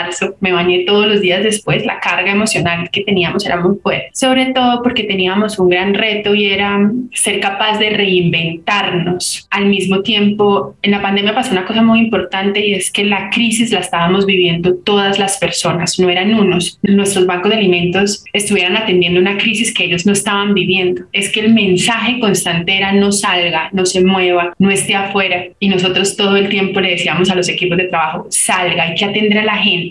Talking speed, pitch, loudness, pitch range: 195 wpm, 195 Hz, -13 LUFS, 180-205 Hz